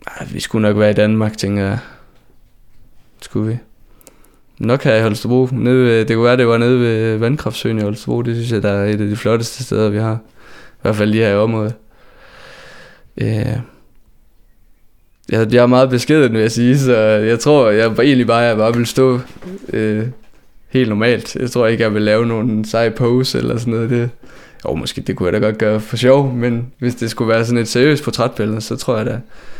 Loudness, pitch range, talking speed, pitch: -15 LUFS, 110-125 Hz, 200 wpm, 115 Hz